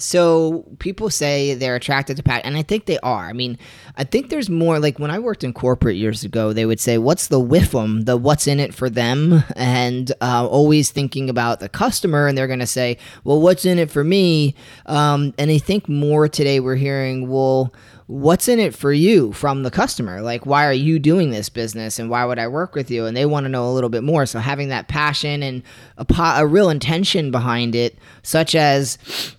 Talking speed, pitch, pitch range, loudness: 225 wpm, 140 Hz, 125-155 Hz, -18 LUFS